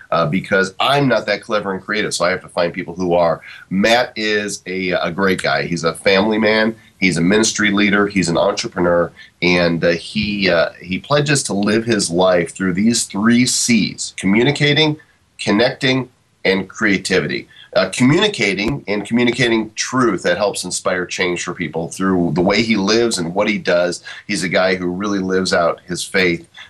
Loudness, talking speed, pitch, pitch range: -16 LUFS, 180 wpm, 100 Hz, 90-110 Hz